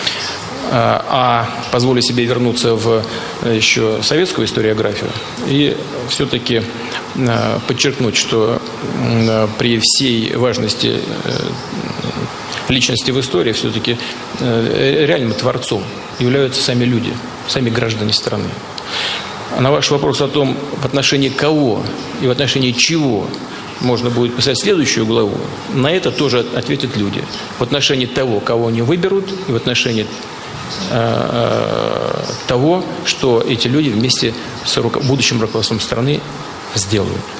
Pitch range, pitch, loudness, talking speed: 115-140 Hz, 125 Hz, -15 LUFS, 110 wpm